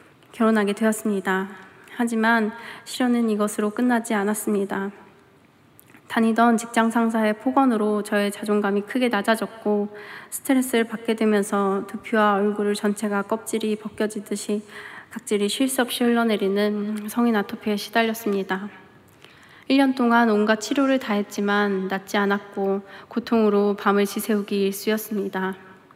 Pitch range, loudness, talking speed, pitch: 205-230 Hz, -23 LUFS, 310 characters per minute, 210 Hz